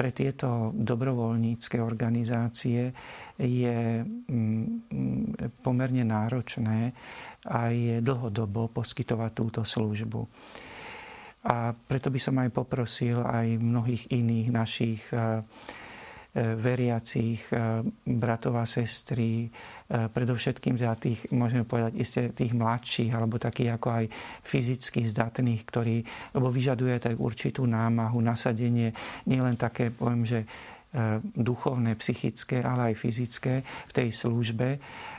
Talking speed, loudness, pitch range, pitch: 105 wpm, -29 LUFS, 115-125 Hz, 120 Hz